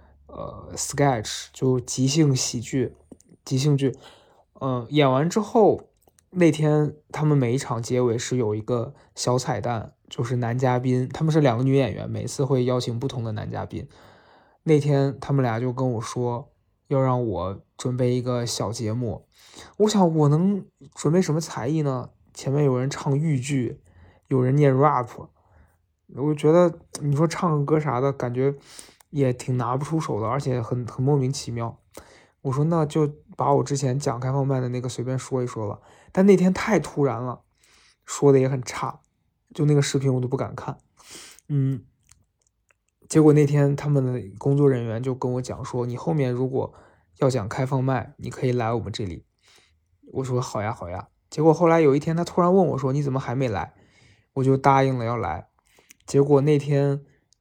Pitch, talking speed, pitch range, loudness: 130 Hz, 260 characters per minute, 120-145 Hz, -23 LUFS